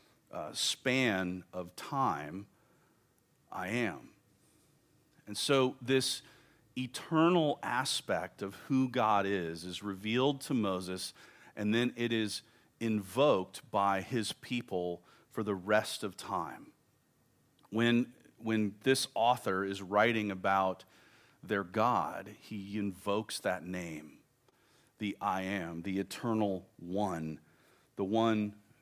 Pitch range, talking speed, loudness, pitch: 95-125 Hz, 110 wpm, -34 LUFS, 105 Hz